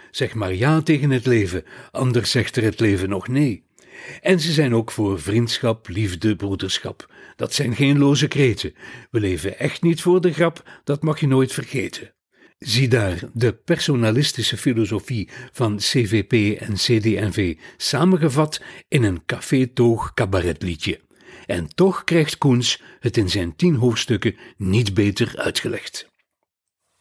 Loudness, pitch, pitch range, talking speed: -20 LUFS, 120 Hz, 105-140 Hz, 140 wpm